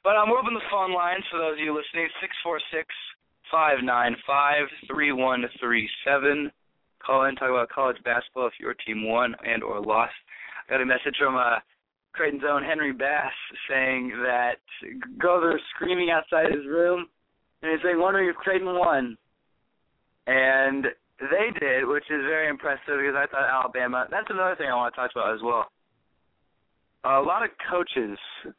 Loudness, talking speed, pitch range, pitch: -25 LUFS, 185 wpm, 130-175 Hz, 145 Hz